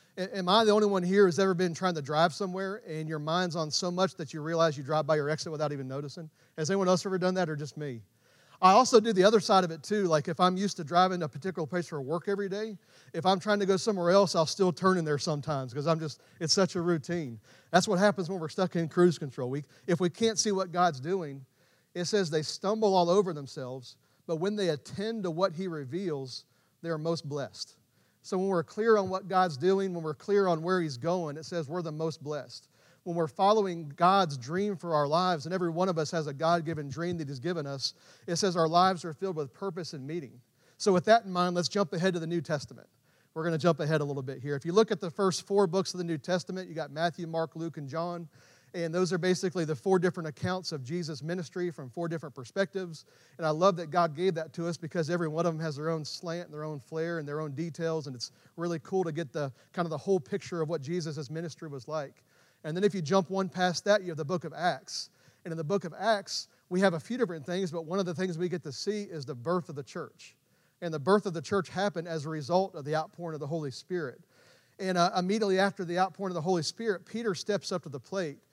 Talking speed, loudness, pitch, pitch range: 260 wpm, -30 LUFS, 170 Hz, 155-190 Hz